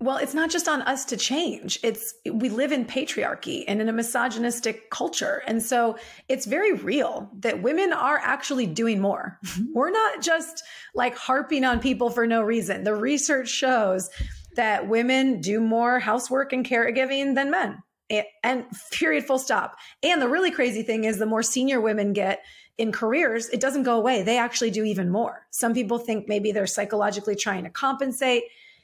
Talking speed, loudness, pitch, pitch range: 180 wpm, -24 LUFS, 240 Hz, 220-270 Hz